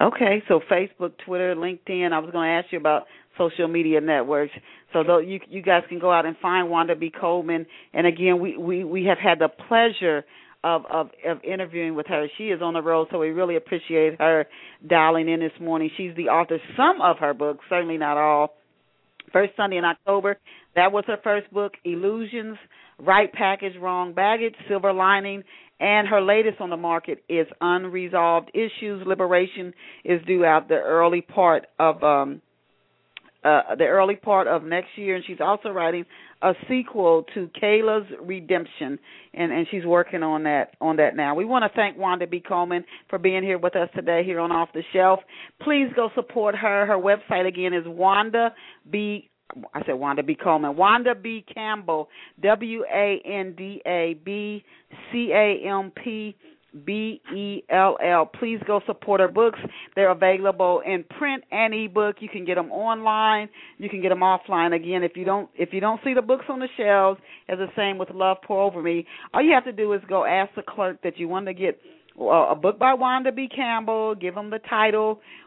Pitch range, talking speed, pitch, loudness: 170-210 Hz, 195 wpm, 185 Hz, -22 LUFS